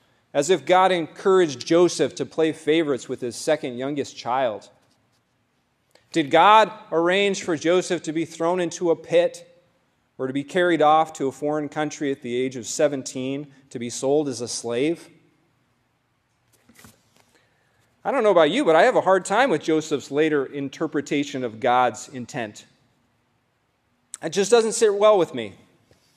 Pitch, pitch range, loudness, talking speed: 150 Hz, 125-165 Hz, -22 LUFS, 160 wpm